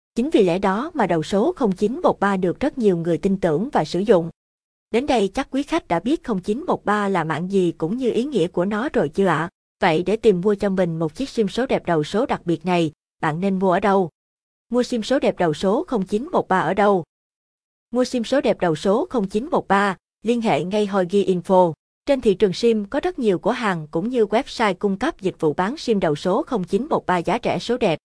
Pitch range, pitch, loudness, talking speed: 180-235 Hz, 200 Hz, -21 LUFS, 225 wpm